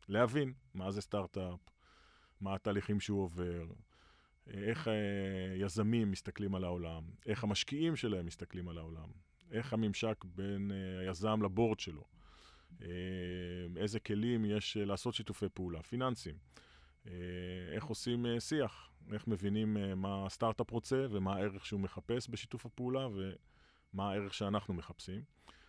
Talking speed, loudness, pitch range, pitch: 115 wpm, -39 LUFS, 90-110 Hz, 100 Hz